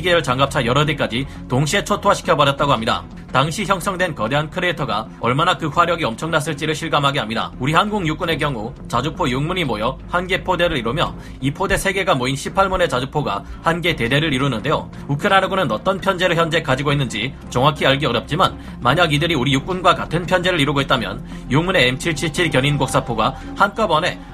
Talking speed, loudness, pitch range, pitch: 415 characters per minute, -18 LUFS, 135-180 Hz, 155 Hz